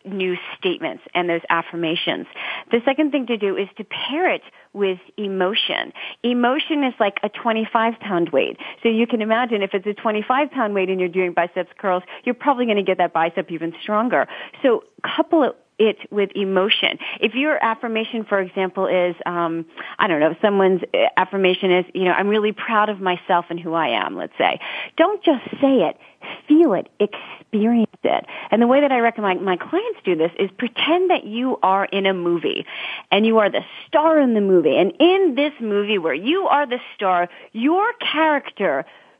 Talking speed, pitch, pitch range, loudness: 195 wpm, 215 Hz, 185-280 Hz, -20 LUFS